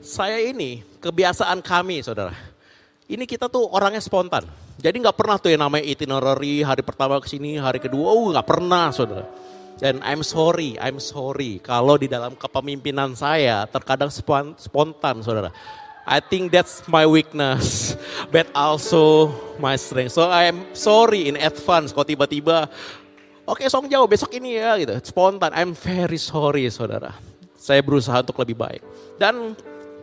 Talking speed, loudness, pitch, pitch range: 150 wpm, -20 LUFS, 145 Hz, 135-175 Hz